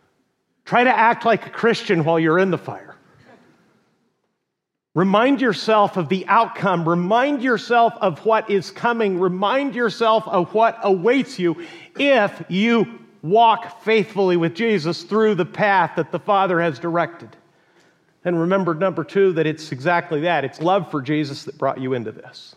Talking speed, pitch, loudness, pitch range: 155 wpm, 190 Hz, -19 LUFS, 170-220 Hz